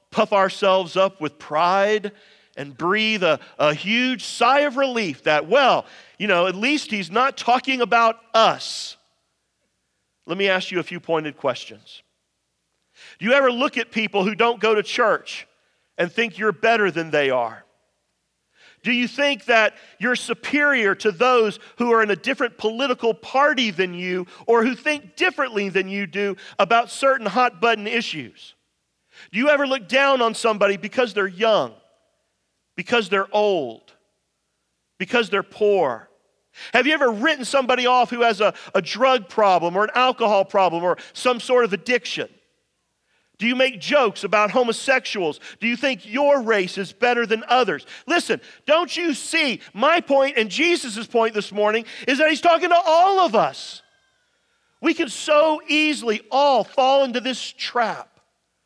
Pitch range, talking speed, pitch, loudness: 200-265 Hz, 165 wpm, 230 Hz, -20 LUFS